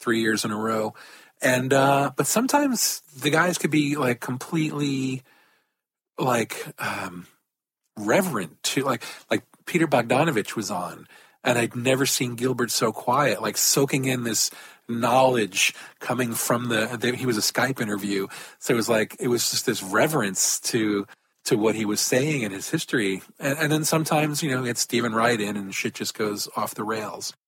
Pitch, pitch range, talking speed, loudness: 125 Hz, 110-140 Hz, 175 wpm, -24 LUFS